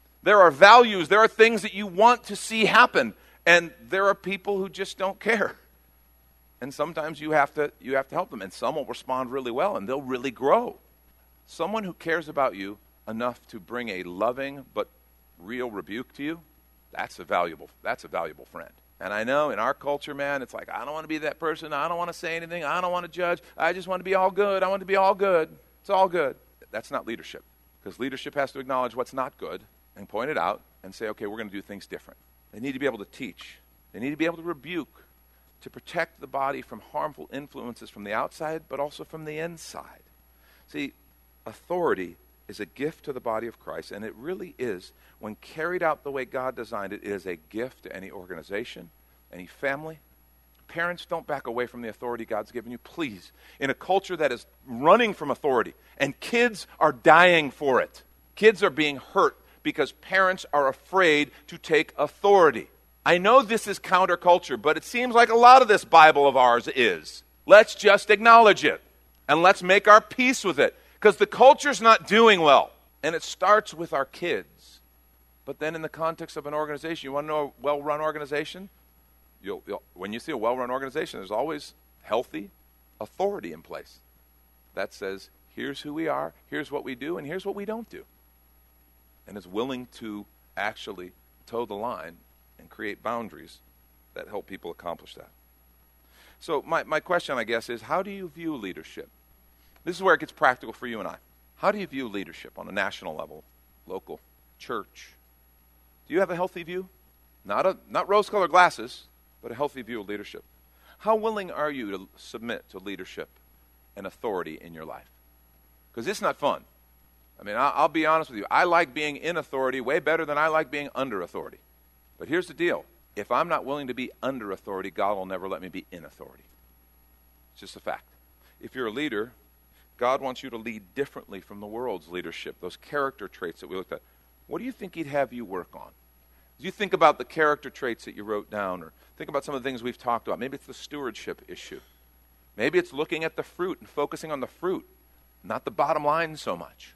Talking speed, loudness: 210 wpm, -24 LUFS